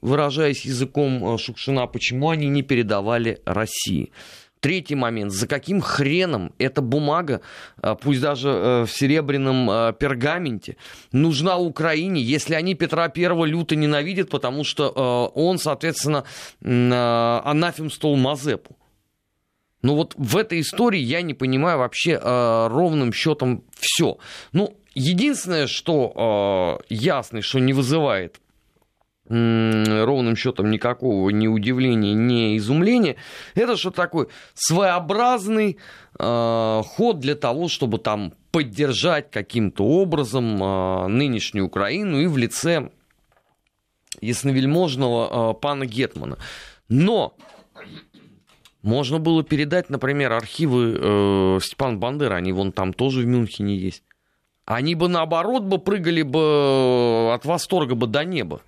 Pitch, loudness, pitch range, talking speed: 135 Hz, -21 LUFS, 115-160 Hz, 110 wpm